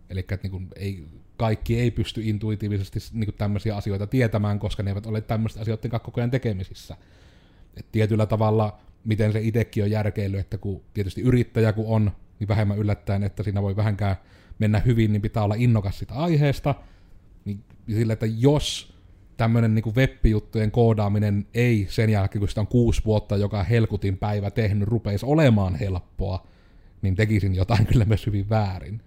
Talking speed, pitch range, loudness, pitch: 165 wpm, 100-110 Hz, -24 LUFS, 105 Hz